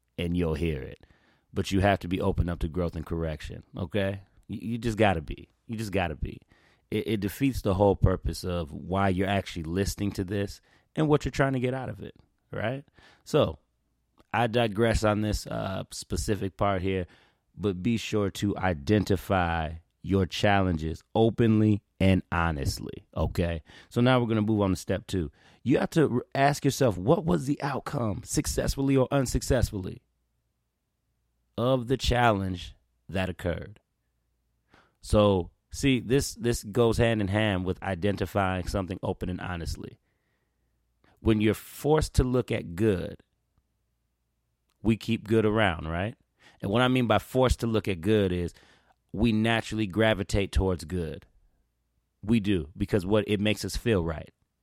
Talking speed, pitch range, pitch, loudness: 160 wpm, 90-115 Hz, 100 Hz, -28 LUFS